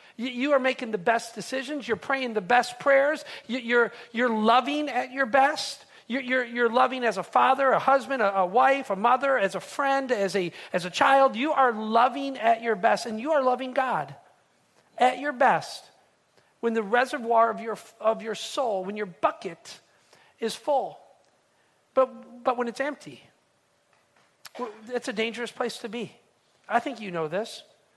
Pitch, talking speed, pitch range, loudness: 245 Hz, 175 wpm, 225-270 Hz, -25 LUFS